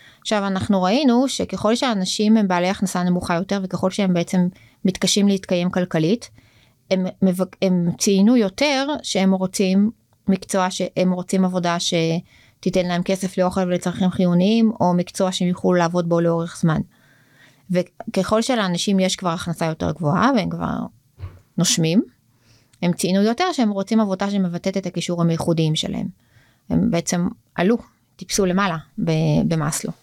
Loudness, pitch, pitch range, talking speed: -20 LUFS, 185 Hz, 170-200 Hz, 135 wpm